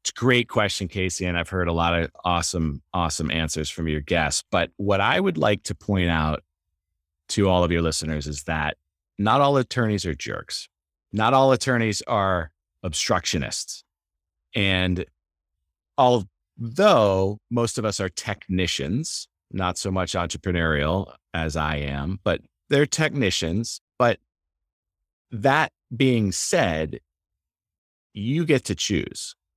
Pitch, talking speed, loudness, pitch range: 90 Hz, 135 wpm, -23 LUFS, 80-105 Hz